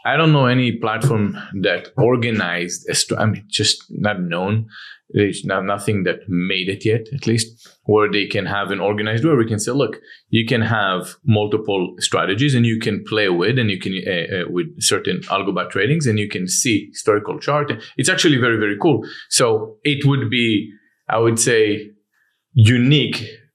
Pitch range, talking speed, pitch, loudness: 105-125 Hz, 180 wpm, 110 Hz, -18 LUFS